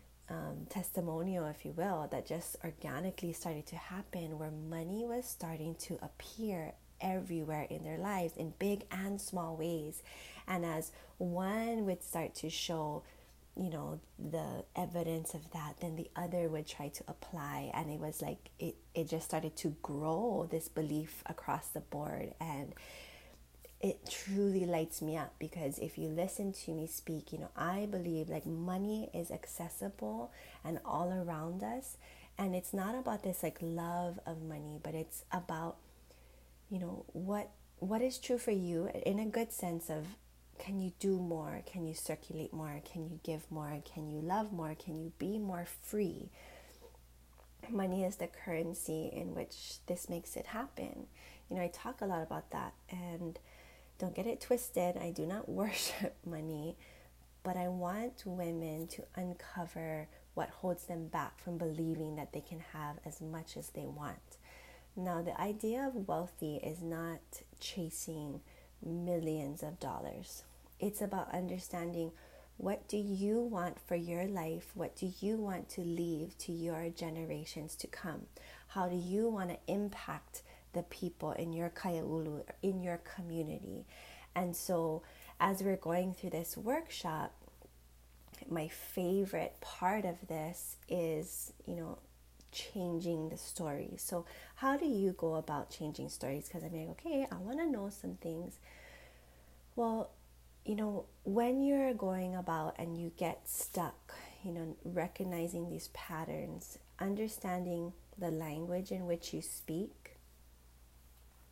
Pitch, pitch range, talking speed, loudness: 170 Hz, 155-185 Hz, 155 wpm, -40 LUFS